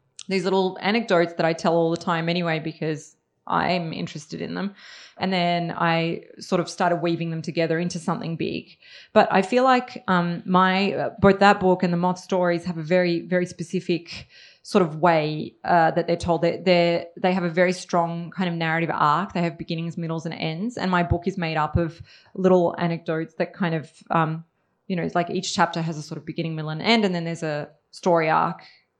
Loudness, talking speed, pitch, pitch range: -23 LUFS, 210 wpm, 175 Hz, 165-185 Hz